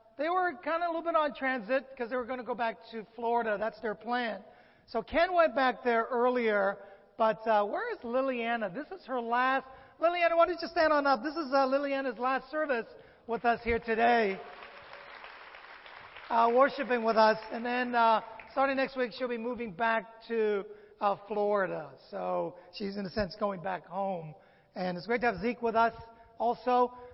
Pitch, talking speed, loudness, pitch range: 235 Hz, 190 wpm, -30 LUFS, 220-265 Hz